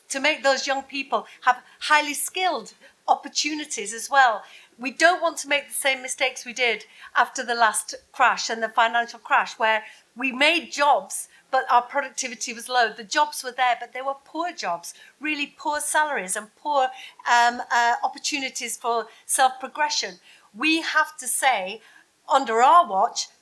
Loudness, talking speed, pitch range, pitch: -23 LUFS, 165 wpm, 240-300 Hz, 265 Hz